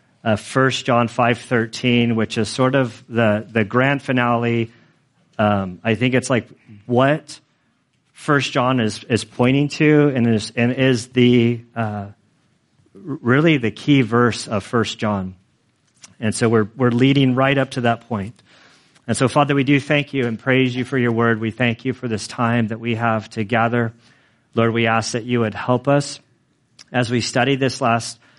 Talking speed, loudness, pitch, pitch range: 180 wpm, -19 LUFS, 120 Hz, 115-130 Hz